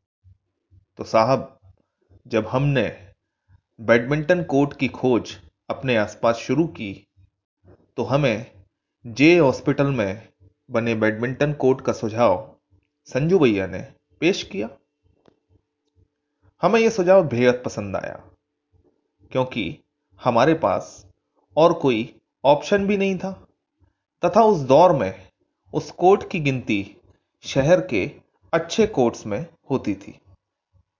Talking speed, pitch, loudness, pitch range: 110 wpm, 120 Hz, -21 LUFS, 100-145 Hz